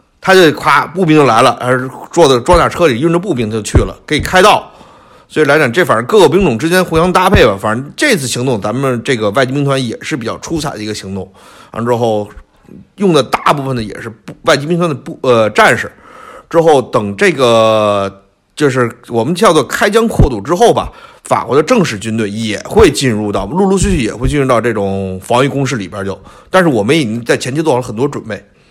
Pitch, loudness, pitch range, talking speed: 125 Hz, -11 LUFS, 105-150 Hz, 325 characters per minute